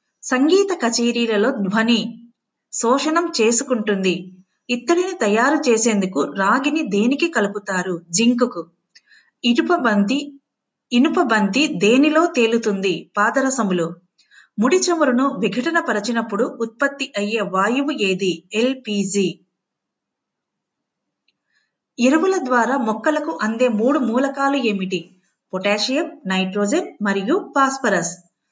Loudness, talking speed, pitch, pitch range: -19 LUFS, 80 wpm, 235 Hz, 200-275 Hz